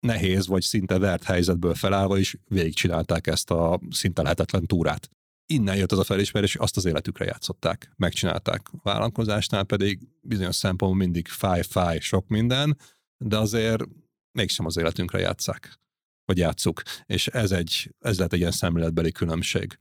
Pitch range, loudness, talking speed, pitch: 90-110 Hz, -25 LUFS, 150 wpm, 95 Hz